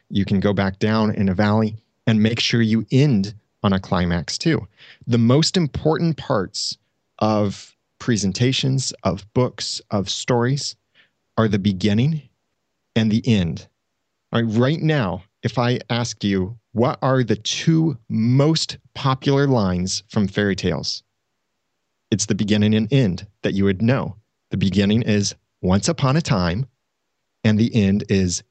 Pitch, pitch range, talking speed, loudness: 110 Hz, 100-130 Hz, 150 wpm, -20 LUFS